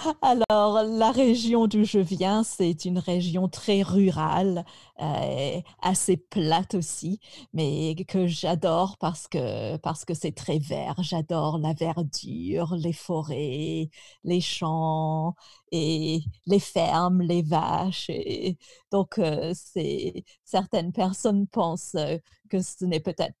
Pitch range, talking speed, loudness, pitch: 160-195 Hz, 125 wpm, -26 LUFS, 175 Hz